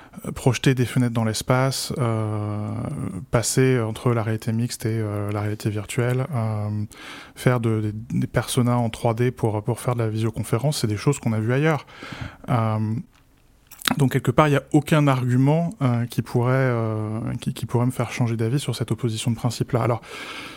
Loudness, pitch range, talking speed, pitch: -23 LUFS, 110-130 Hz, 185 wpm, 120 Hz